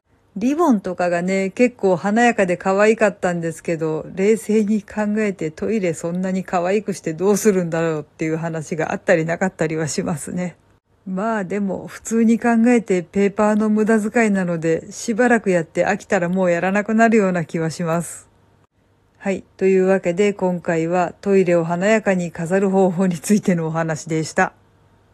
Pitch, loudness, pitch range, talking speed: 185 Hz, -19 LUFS, 165-205 Hz, 360 characters per minute